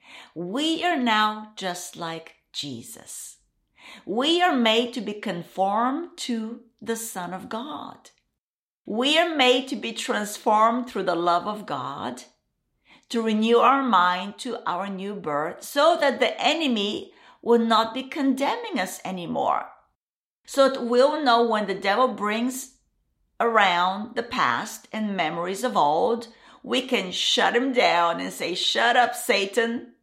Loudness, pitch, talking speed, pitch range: -23 LUFS, 230 Hz, 140 wpm, 195-255 Hz